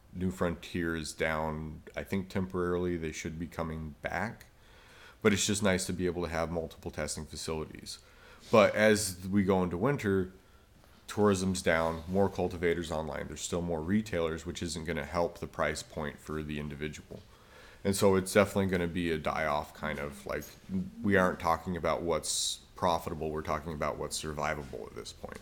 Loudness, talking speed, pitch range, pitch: -32 LUFS, 180 wpm, 80-95 Hz, 85 Hz